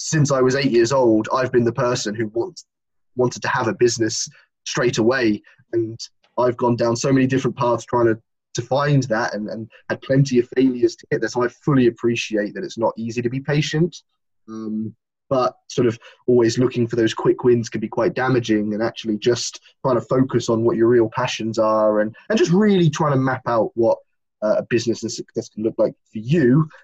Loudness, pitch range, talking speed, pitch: -20 LUFS, 110-130 Hz, 215 wpm, 120 Hz